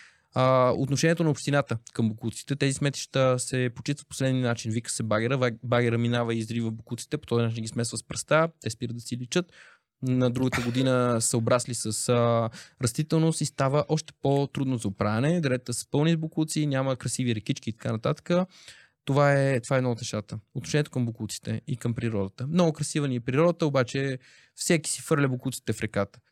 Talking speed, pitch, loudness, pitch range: 180 wpm, 130 Hz, -27 LUFS, 115-145 Hz